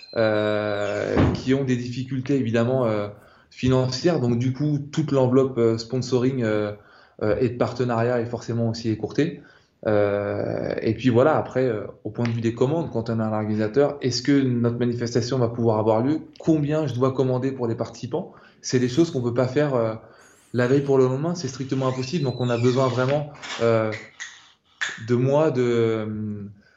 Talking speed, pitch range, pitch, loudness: 185 wpm, 115-135 Hz, 125 Hz, -23 LUFS